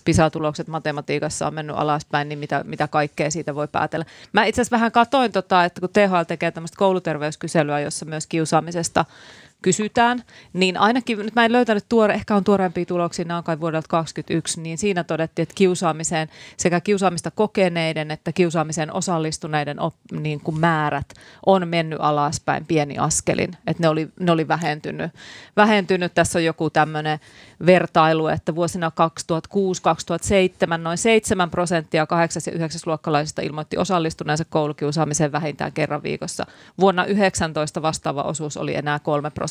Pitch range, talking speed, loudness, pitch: 155-185 Hz, 150 wpm, -21 LUFS, 165 Hz